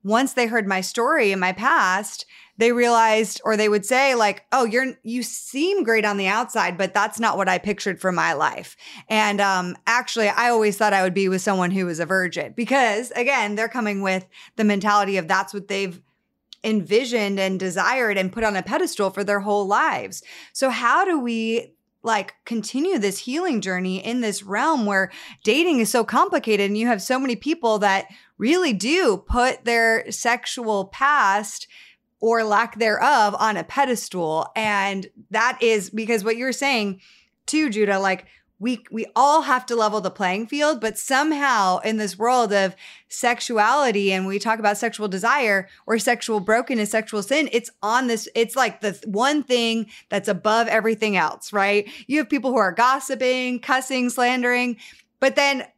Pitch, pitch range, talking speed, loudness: 225 Hz, 200-245 Hz, 180 wpm, -21 LUFS